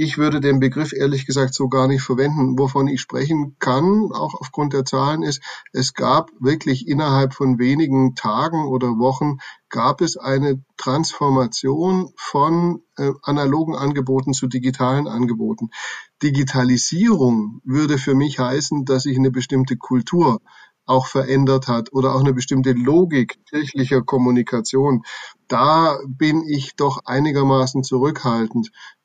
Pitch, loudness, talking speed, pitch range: 135 Hz, -19 LUFS, 135 wpm, 130-145 Hz